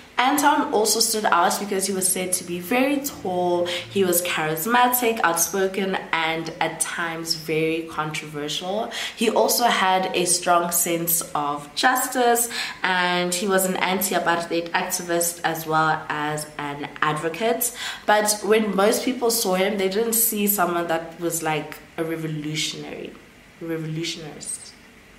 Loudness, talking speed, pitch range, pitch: -22 LUFS, 140 wpm, 165-210 Hz, 175 Hz